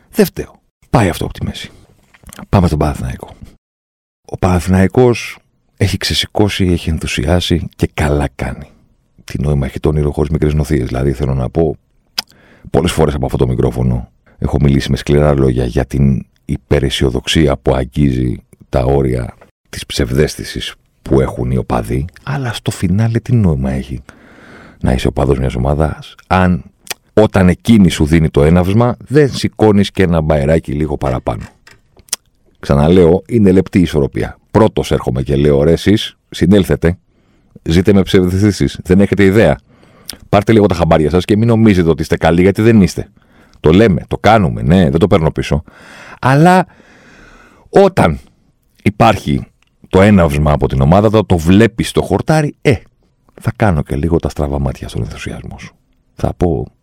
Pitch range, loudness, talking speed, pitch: 70-100 Hz, -13 LUFS, 155 wpm, 80 Hz